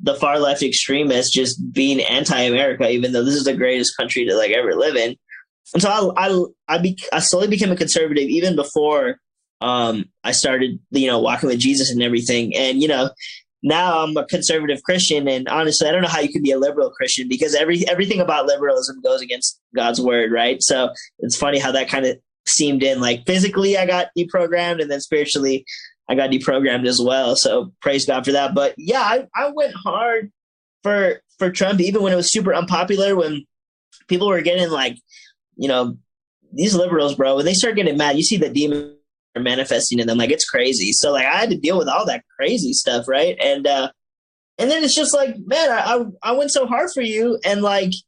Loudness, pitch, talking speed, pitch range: -18 LUFS, 160 Hz, 210 wpm, 135-200 Hz